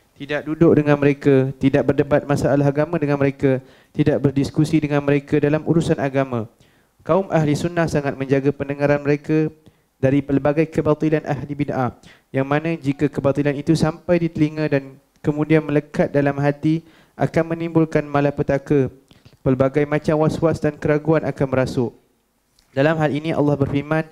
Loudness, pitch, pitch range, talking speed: -20 LUFS, 145 Hz, 140-155 Hz, 140 wpm